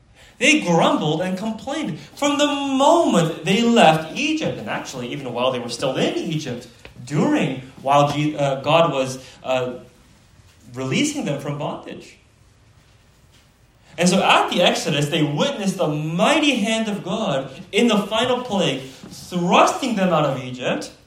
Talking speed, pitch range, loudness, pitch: 140 wpm, 130-225 Hz, -20 LUFS, 165 Hz